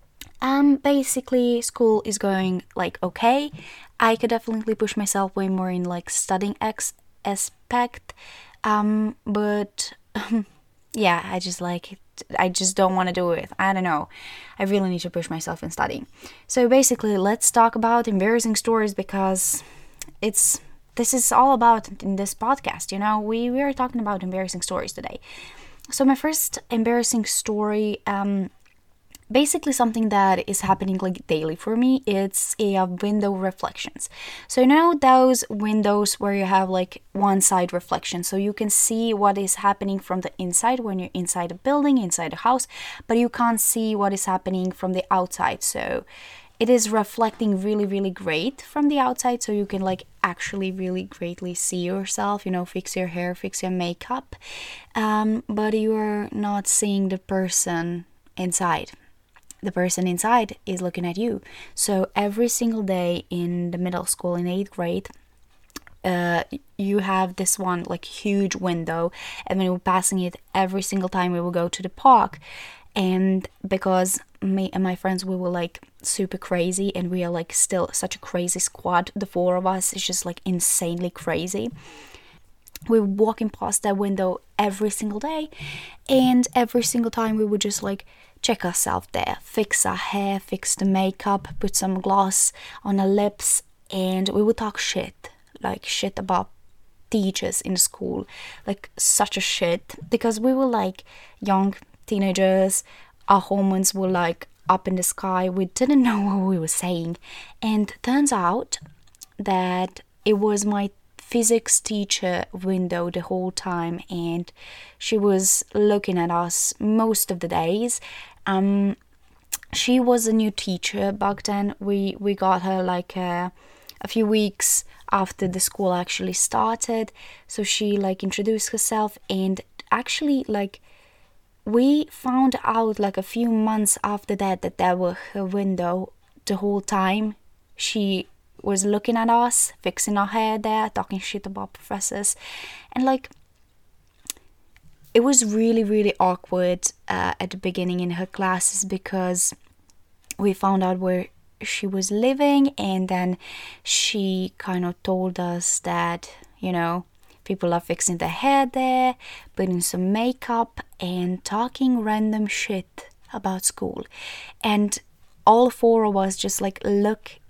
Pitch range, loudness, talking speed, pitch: 185-220 Hz, -22 LUFS, 155 wpm, 200 Hz